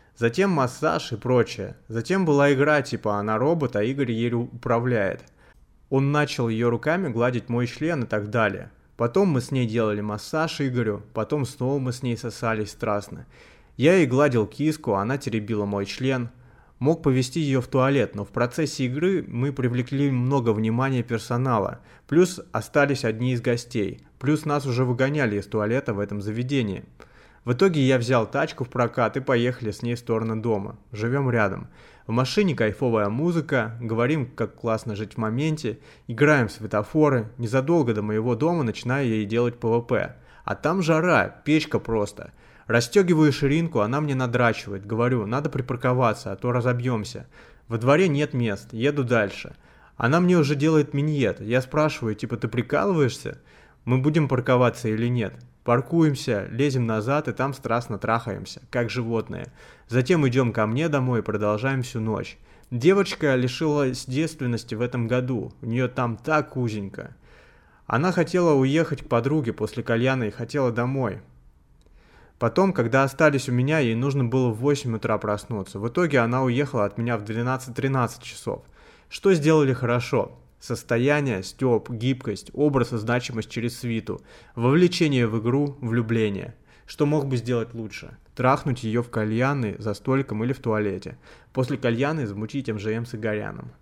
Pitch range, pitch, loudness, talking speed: 115-140 Hz, 125 Hz, -24 LUFS, 155 wpm